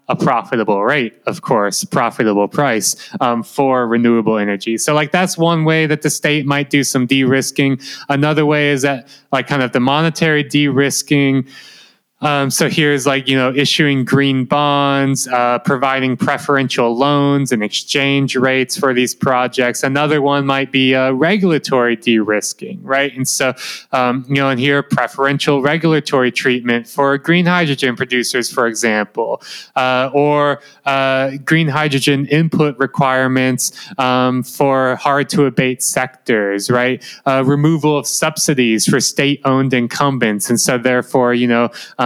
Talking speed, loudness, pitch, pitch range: 145 wpm, -15 LUFS, 135 Hz, 125-145 Hz